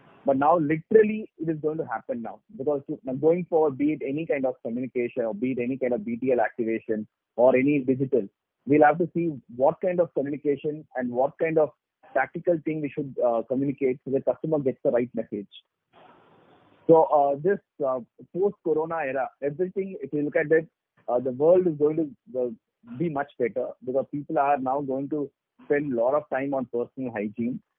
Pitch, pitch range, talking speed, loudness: 145 Hz, 130-160 Hz, 190 wpm, -26 LUFS